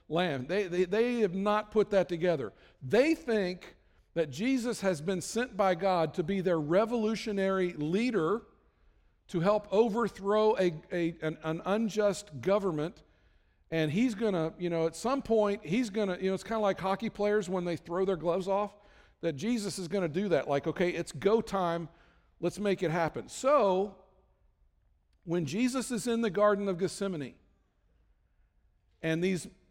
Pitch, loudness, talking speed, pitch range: 190 Hz, -31 LUFS, 165 wpm, 165-210 Hz